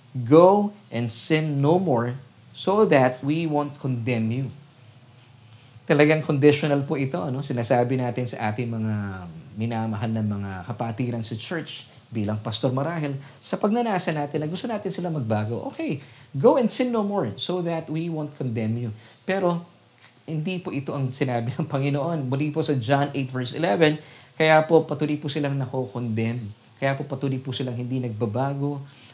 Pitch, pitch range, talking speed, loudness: 135 Hz, 120-155 Hz, 165 wpm, -24 LUFS